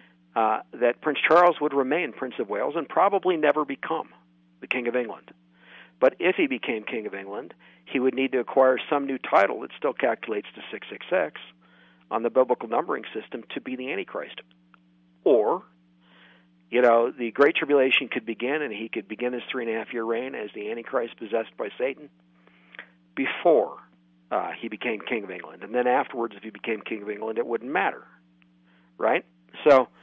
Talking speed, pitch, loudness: 185 wpm, 115 Hz, -25 LUFS